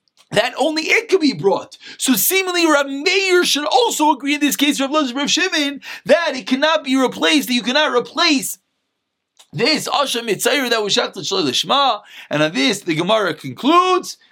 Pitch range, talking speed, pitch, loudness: 250-325 Hz, 165 wpm, 285 Hz, -16 LUFS